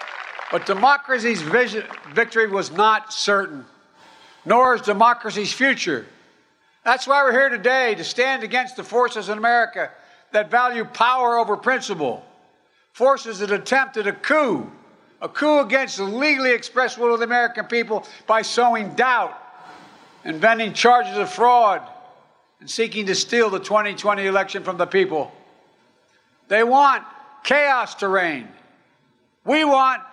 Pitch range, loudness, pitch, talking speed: 210-260 Hz, -19 LUFS, 235 Hz, 135 wpm